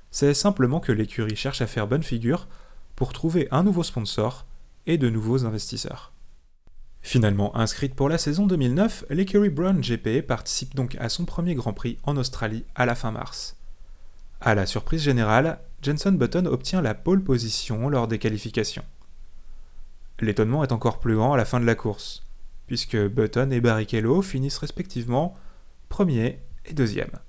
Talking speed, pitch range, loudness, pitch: 160 wpm, 110-145 Hz, -24 LUFS, 120 Hz